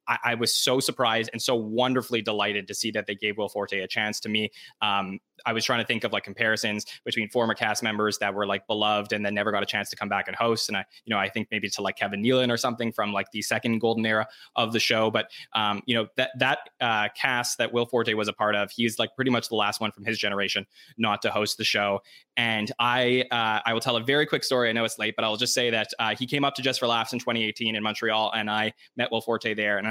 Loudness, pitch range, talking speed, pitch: -26 LUFS, 105-120 Hz, 275 wpm, 110 Hz